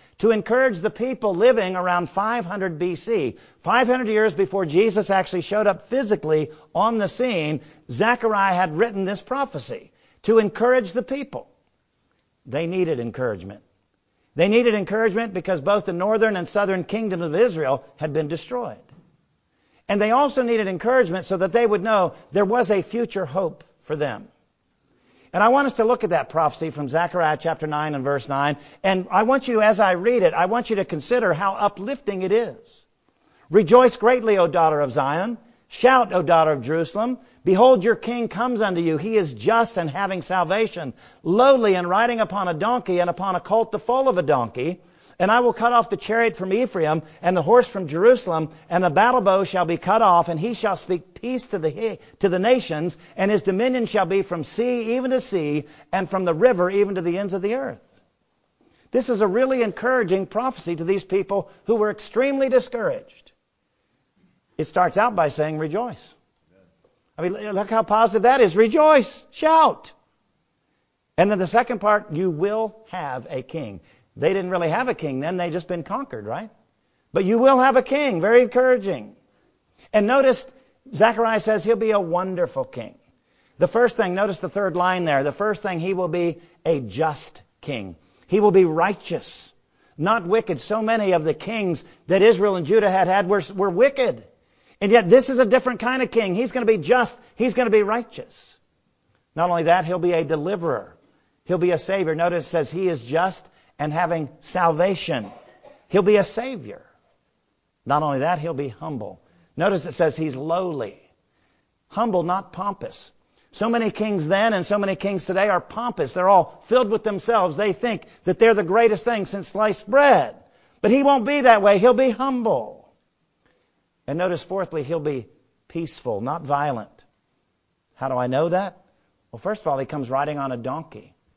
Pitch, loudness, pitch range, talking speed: 195 Hz, -21 LUFS, 170-230 Hz, 185 wpm